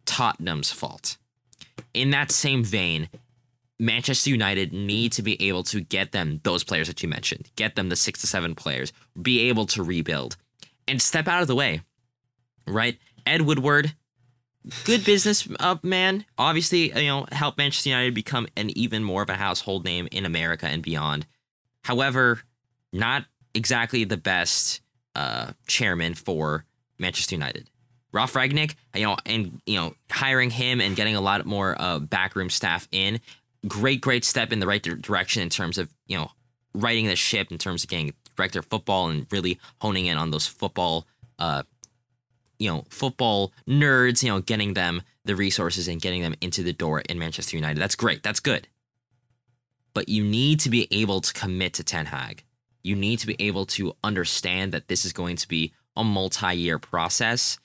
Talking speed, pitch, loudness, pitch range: 175 wpm, 110 Hz, -24 LUFS, 90-125 Hz